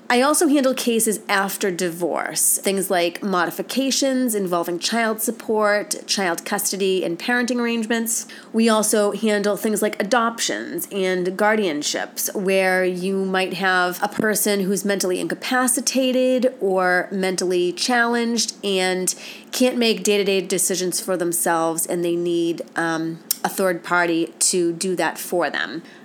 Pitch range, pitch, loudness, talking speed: 180-230 Hz, 200 Hz, -20 LUFS, 135 wpm